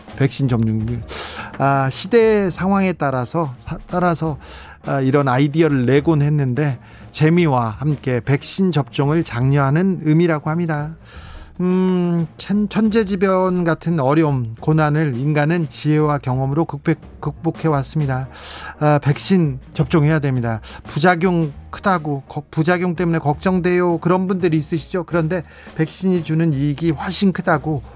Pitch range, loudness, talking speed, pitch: 135-175 Hz, -18 LUFS, 285 characters per minute, 155 Hz